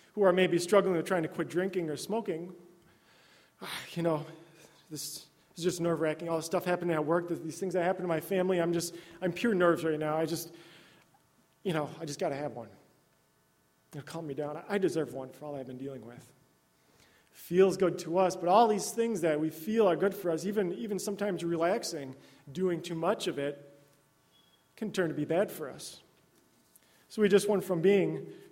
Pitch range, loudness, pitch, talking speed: 145-185 Hz, -31 LUFS, 165 Hz, 205 wpm